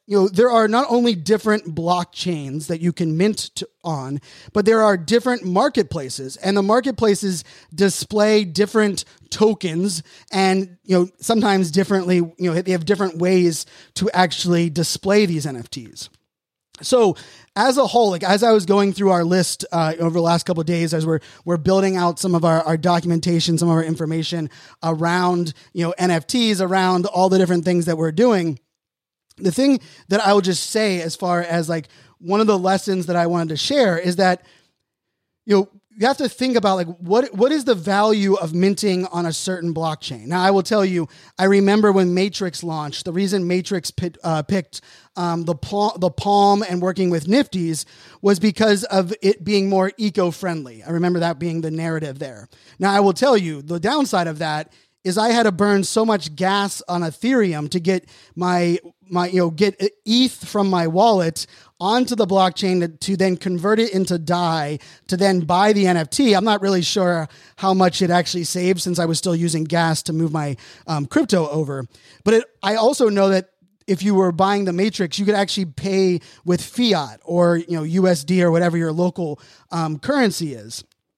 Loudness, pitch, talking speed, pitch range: -19 LUFS, 180 Hz, 195 wpm, 170-200 Hz